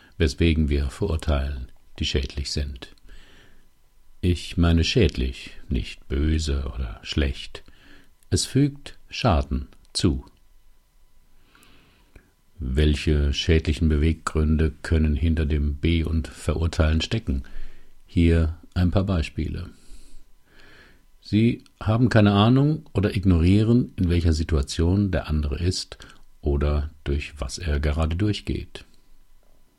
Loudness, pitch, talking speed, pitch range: -24 LUFS, 80 Hz, 100 wpm, 75-90 Hz